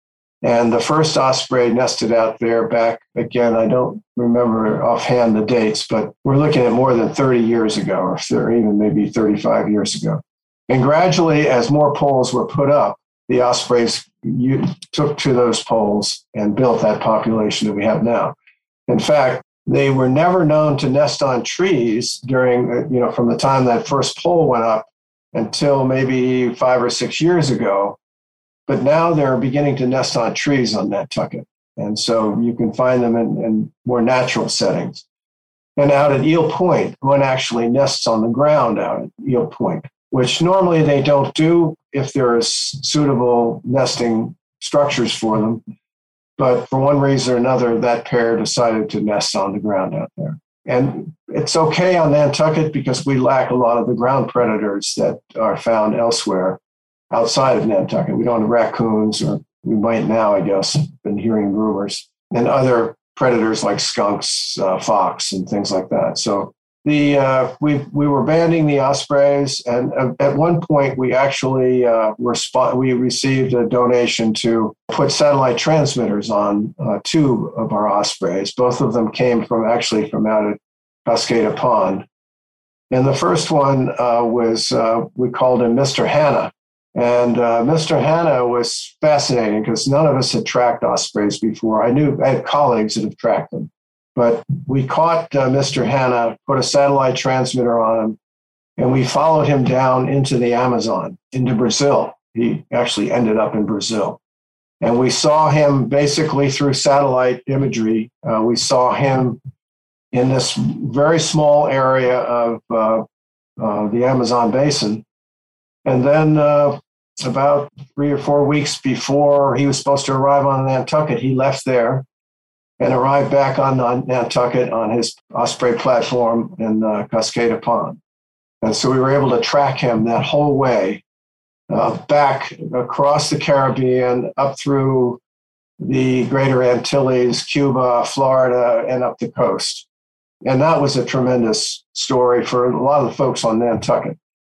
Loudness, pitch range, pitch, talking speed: -16 LUFS, 115-140 Hz, 125 Hz, 165 wpm